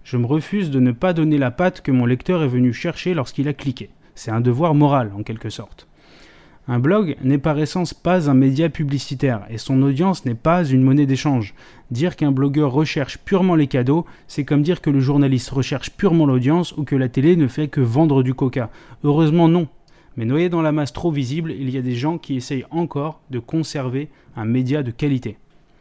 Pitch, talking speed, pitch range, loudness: 145 Hz, 210 wpm, 130-160 Hz, -19 LUFS